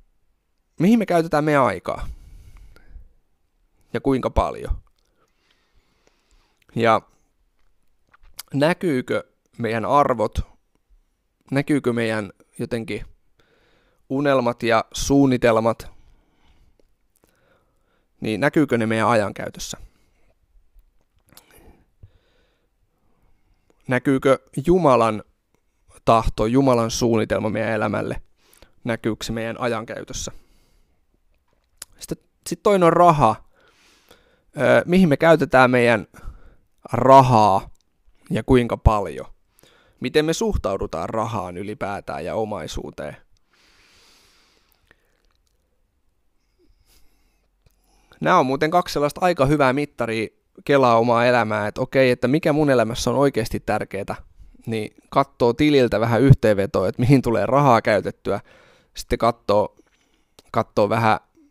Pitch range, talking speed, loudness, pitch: 105-140 Hz, 85 wpm, -20 LUFS, 120 Hz